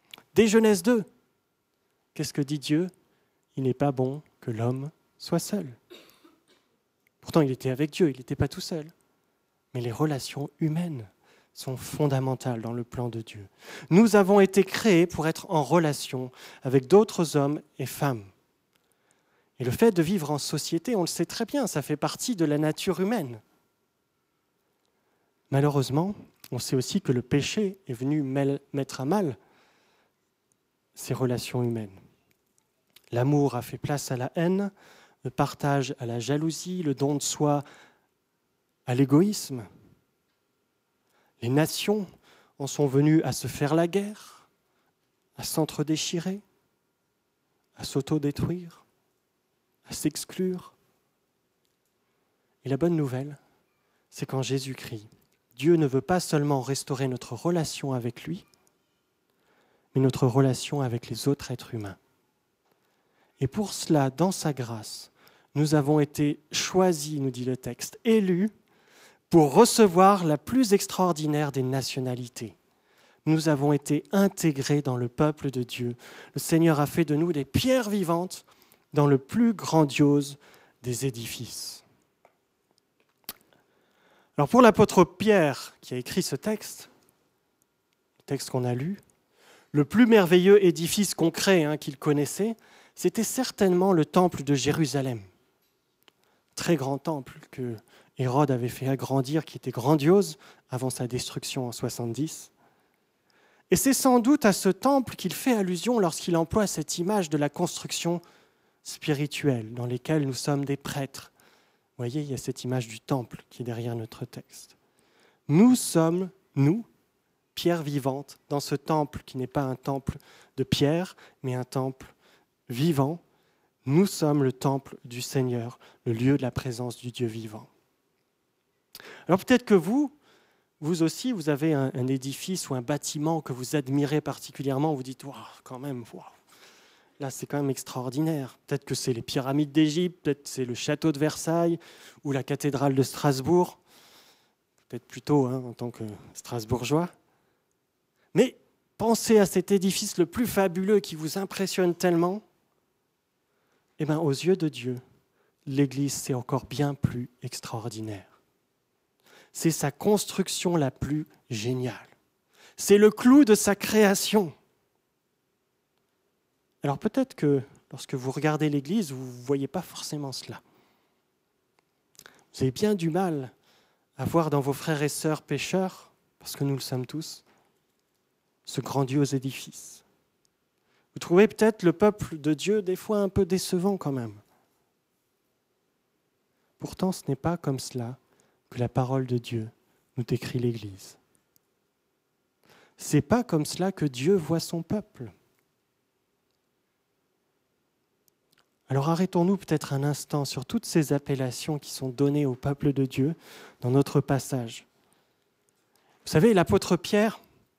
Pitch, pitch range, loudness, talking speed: 145 Hz, 130-175 Hz, -26 LUFS, 140 wpm